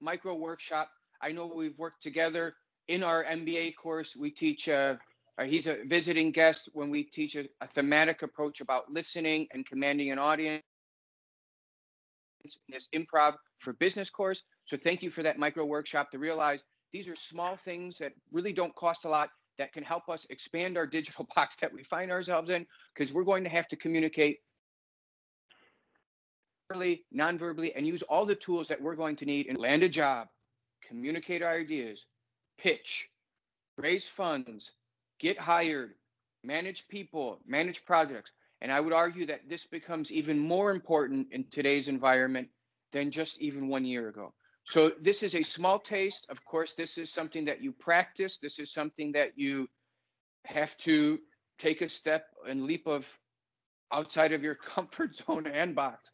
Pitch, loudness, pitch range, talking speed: 160 Hz, -32 LUFS, 145-170 Hz, 165 wpm